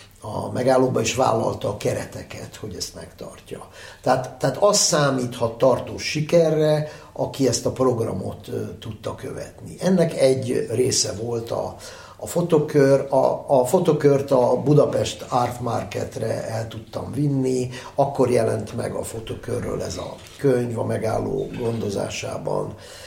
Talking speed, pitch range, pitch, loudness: 125 wpm, 115-140 Hz, 125 Hz, -22 LUFS